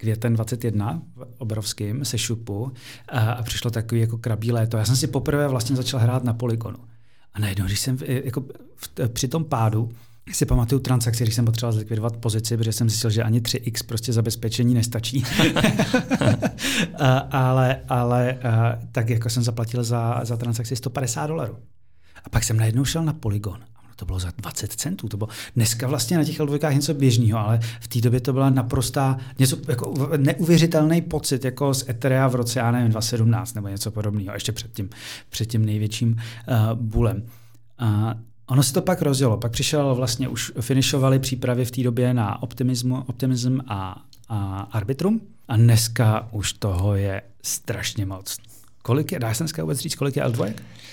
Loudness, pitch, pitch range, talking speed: -23 LUFS, 120 Hz, 115-135 Hz, 170 wpm